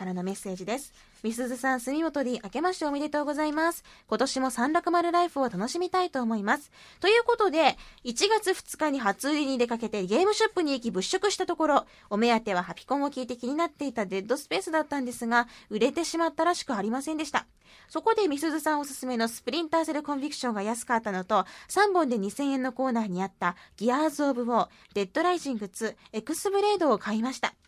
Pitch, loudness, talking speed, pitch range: 270 Hz, -28 LUFS, 470 characters per minute, 230-325 Hz